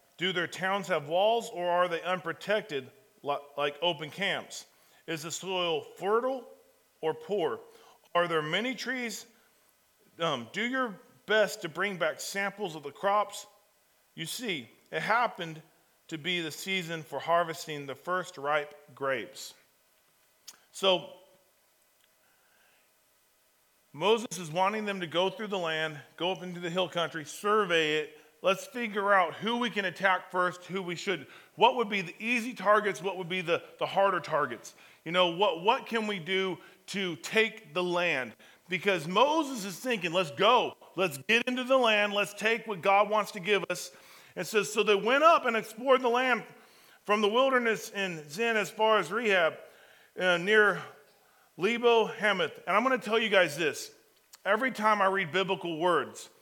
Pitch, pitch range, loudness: 195 Hz, 175-220 Hz, -29 LUFS